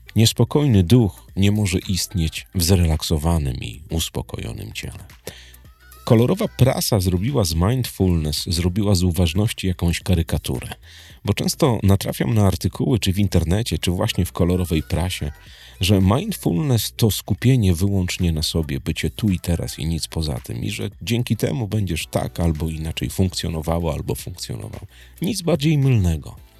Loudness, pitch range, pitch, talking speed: -21 LUFS, 85-110 Hz, 95 Hz, 140 wpm